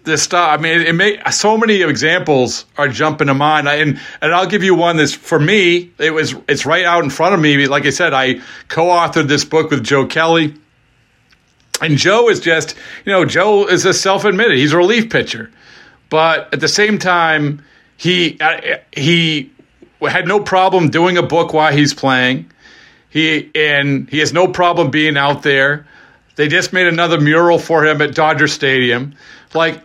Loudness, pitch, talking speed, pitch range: -13 LUFS, 155 Hz, 185 wpm, 145-175 Hz